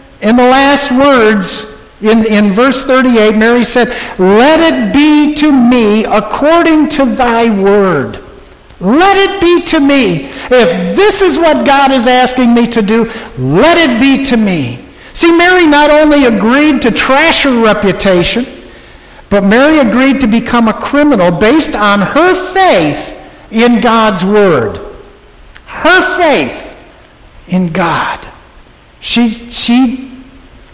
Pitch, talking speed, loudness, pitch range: 250 Hz, 135 wpm, -8 LUFS, 215-290 Hz